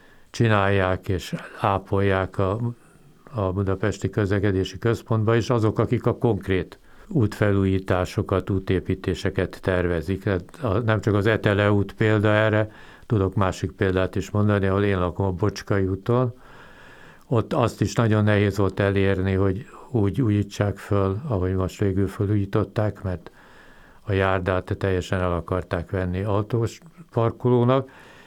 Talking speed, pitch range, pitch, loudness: 125 wpm, 95-110 Hz, 100 Hz, -23 LUFS